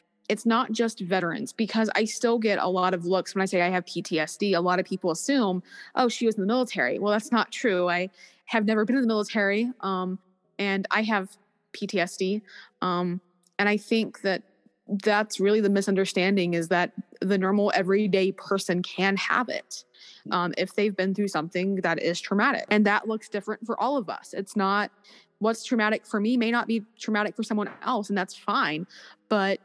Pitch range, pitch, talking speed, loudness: 185-220 Hz, 200 Hz, 195 wpm, -26 LUFS